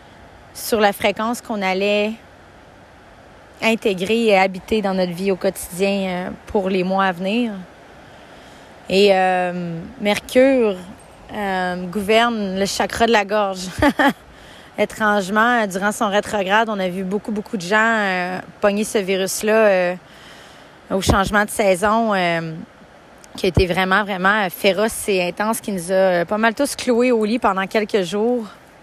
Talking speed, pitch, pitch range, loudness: 145 wpm, 205 Hz, 190-220 Hz, -18 LUFS